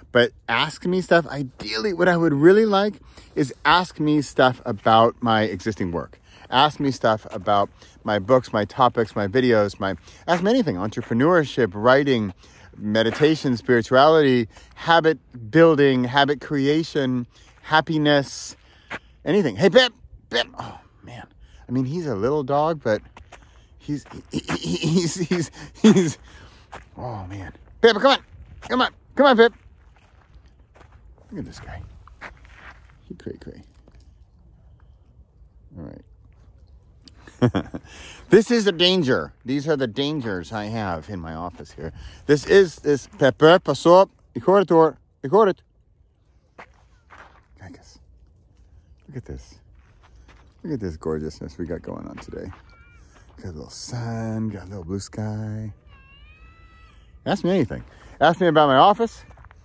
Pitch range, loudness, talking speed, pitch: 90-150 Hz, -20 LUFS, 130 wpm, 115 Hz